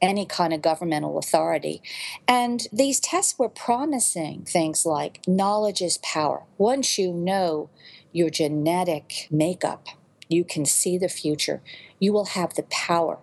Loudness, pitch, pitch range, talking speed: -24 LUFS, 175 Hz, 160-205 Hz, 140 wpm